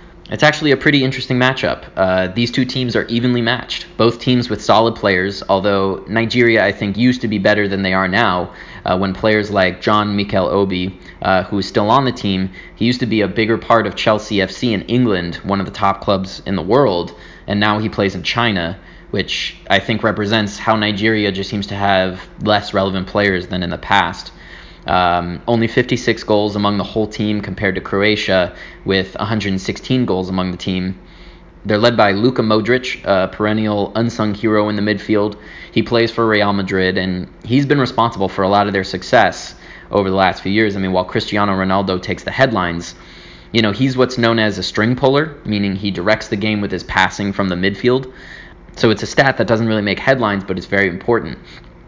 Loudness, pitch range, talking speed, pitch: -16 LUFS, 95-115 Hz, 205 wpm, 105 Hz